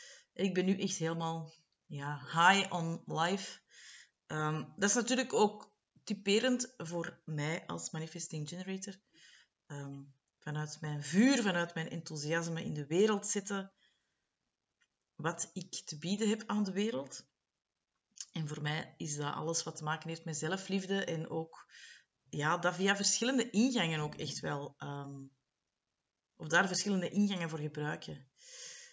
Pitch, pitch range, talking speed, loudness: 170 Hz, 155-200 Hz, 140 wpm, -35 LUFS